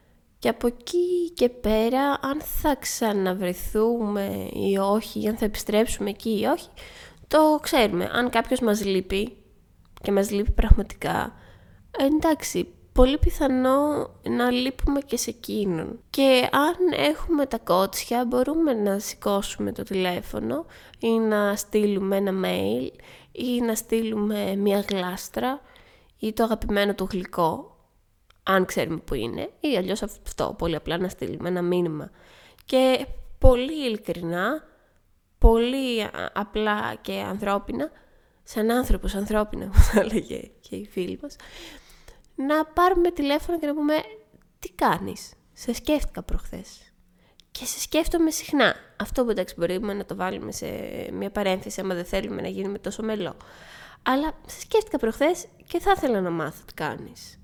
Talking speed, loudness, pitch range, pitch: 140 wpm, -25 LUFS, 195-275 Hz, 225 Hz